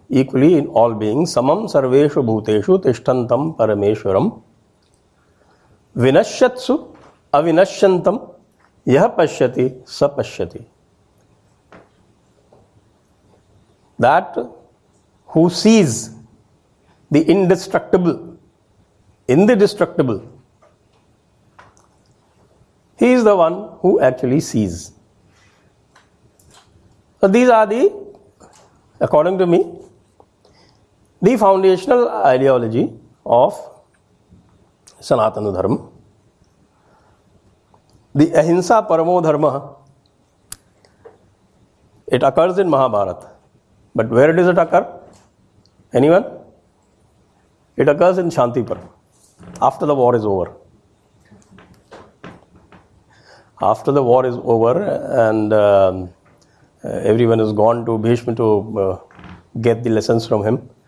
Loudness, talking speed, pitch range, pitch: -16 LUFS, 80 wpm, 105-175 Hz, 125 Hz